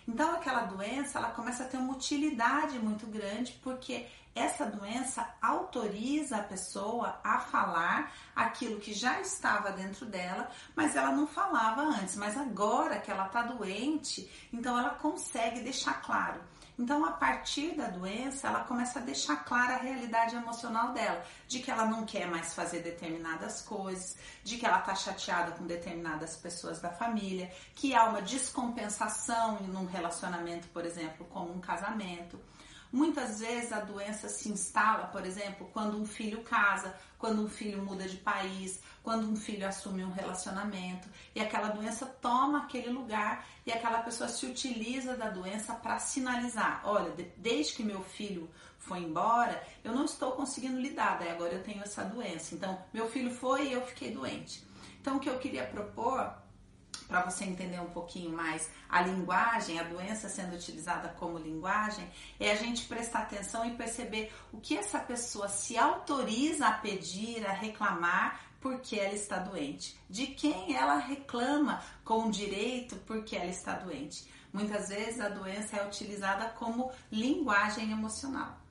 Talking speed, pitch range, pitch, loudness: 160 wpm, 190-245 Hz, 220 Hz, -34 LUFS